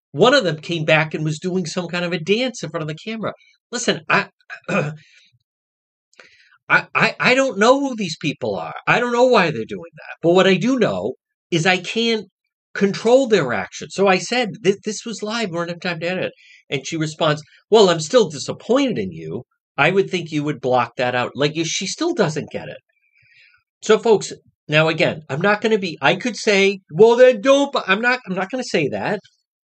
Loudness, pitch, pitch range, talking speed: -18 LUFS, 185 Hz, 160-225 Hz, 215 wpm